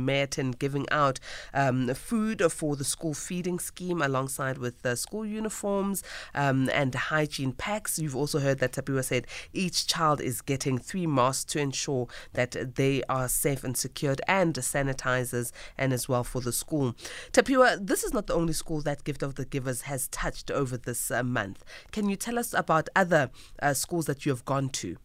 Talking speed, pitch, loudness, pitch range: 185 wpm, 140 Hz, -29 LUFS, 130-165 Hz